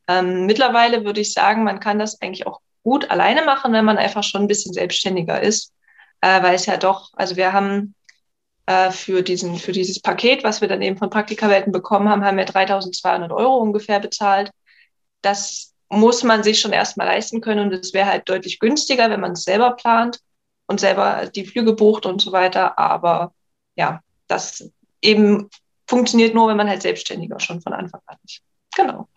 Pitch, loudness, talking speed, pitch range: 205 Hz, -18 LUFS, 190 wpm, 190-220 Hz